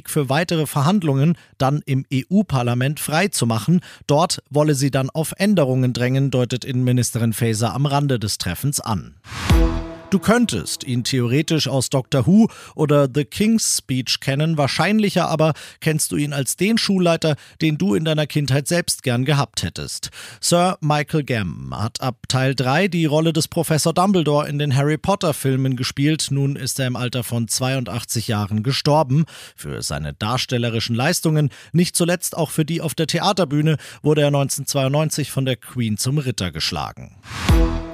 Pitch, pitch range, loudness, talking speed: 140 Hz, 125-160 Hz, -20 LUFS, 155 wpm